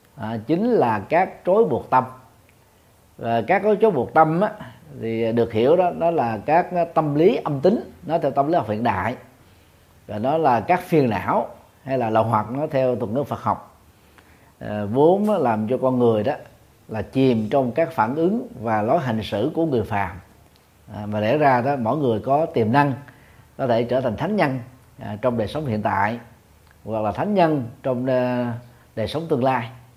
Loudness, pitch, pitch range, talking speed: -21 LUFS, 120 Hz, 110-145 Hz, 200 wpm